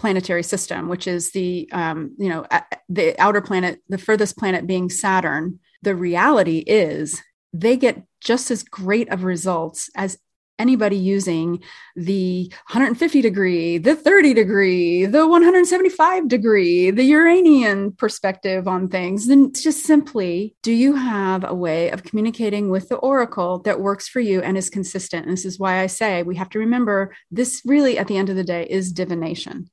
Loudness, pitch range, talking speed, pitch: -18 LUFS, 180-245 Hz, 170 wpm, 195 Hz